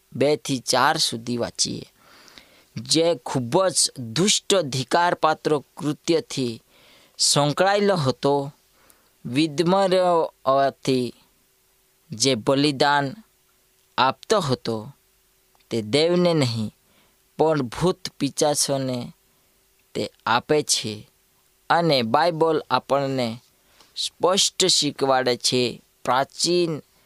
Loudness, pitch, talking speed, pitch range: -22 LUFS, 140 Hz, 75 wpm, 125-165 Hz